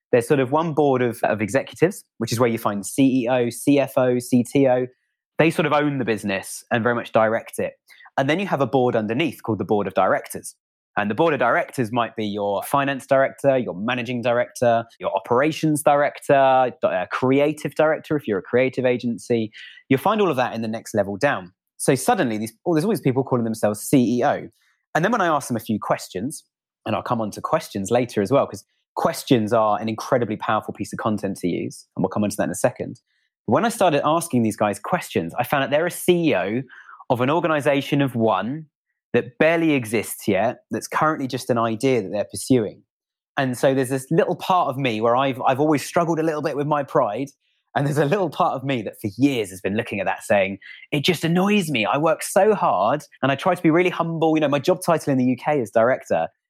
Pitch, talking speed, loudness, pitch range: 135 Hz, 225 wpm, -21 LUFS, 115-155 Hz